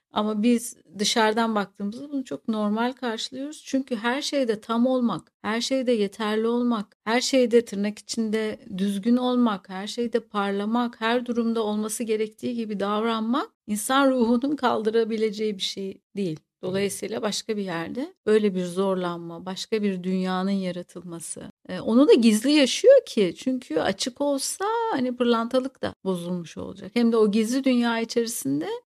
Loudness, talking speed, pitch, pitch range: -24 LUFS, 140 wpm, 225 Hz, 205-245 Hz